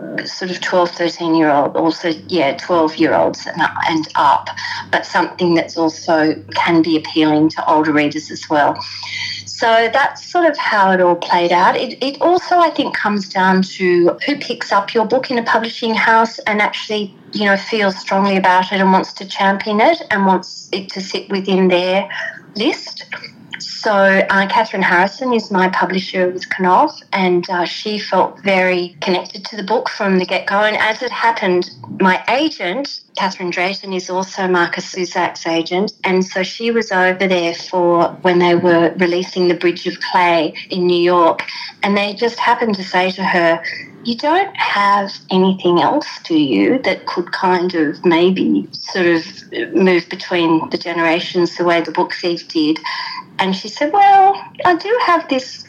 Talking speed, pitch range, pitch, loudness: 175 wpm, 175-225 Hz, 190 Hz, -15 LUFS